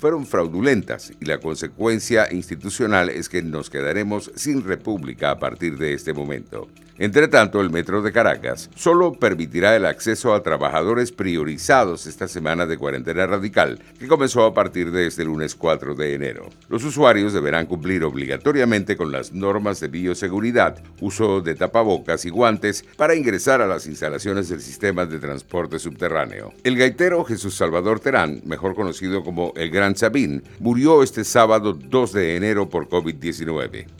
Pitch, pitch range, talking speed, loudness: 95 Hz, 85-110 Hz, 155 wpm, -20 LUFS